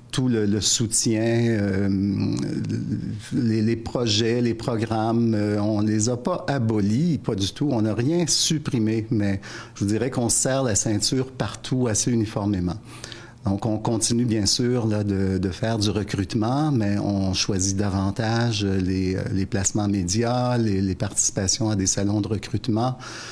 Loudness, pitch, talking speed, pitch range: -23 LUFS, 110 Hz, 155 wpm, 100-120 Hz